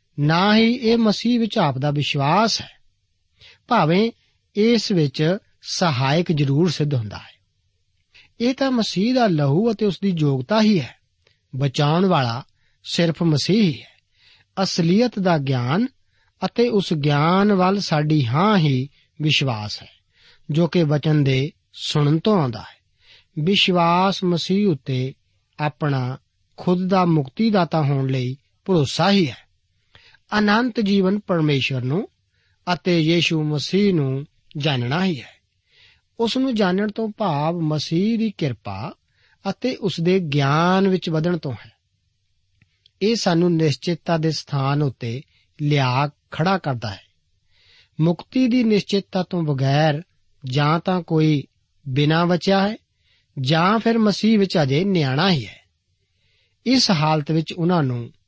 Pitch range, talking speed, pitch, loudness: 130-195 Hz, 130 wpm, 160 Hz, -20 LUFS